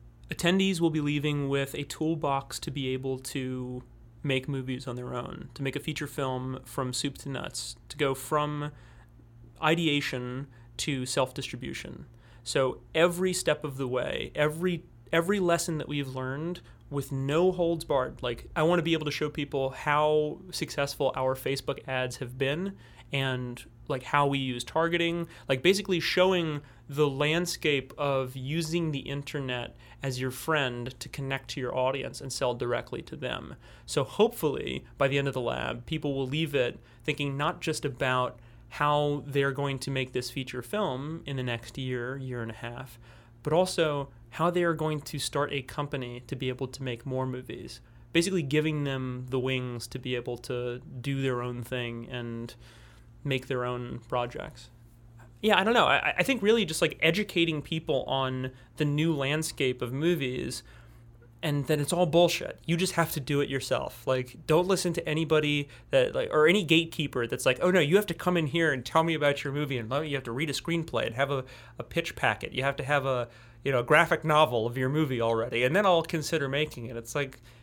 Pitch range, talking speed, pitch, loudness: 125-155 Hz, 195 wpm, 140 Hz, -29 LUFS